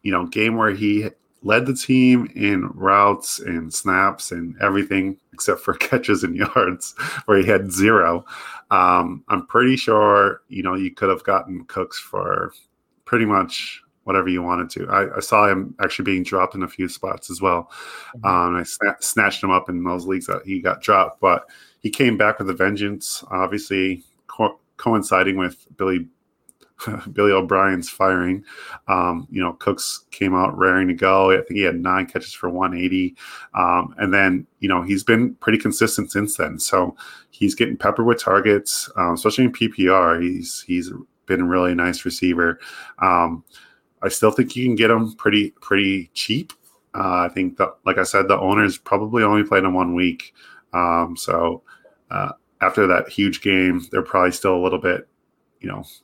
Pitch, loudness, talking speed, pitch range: 95 Hz, -19 LUFS, 180 wpm, 90-105 Hz